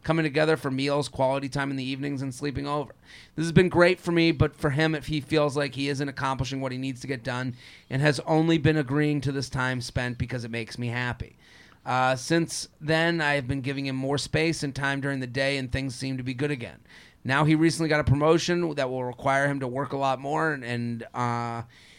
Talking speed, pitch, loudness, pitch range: 240 wpm, 140 Hz, -26 LUFS, 130-150 Hz